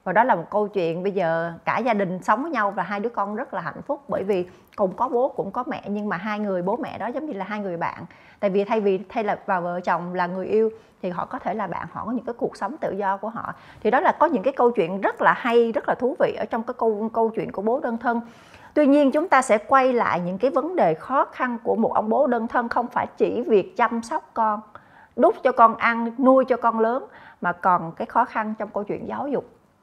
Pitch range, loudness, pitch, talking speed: 200-250 Hz, -23 LUFS, 225 Hz, 280 wpm